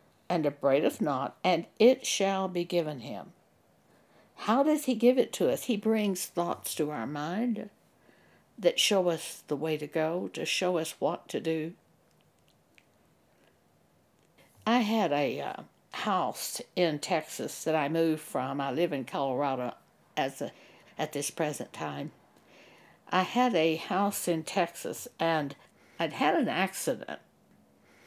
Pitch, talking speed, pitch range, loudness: 175 Hz, 140 wpm, 160-215 Hz, -30 LUFS